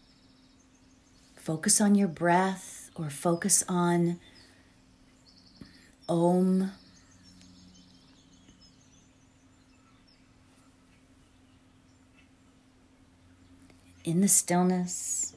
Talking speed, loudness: 45 wpm, -26 LUFS